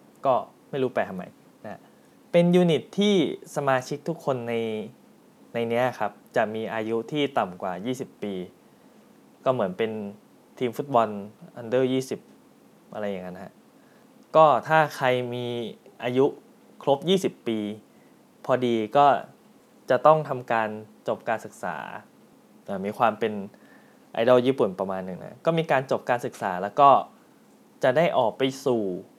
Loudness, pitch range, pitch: -25 LUFS, 110-155 Hz, 125 Hz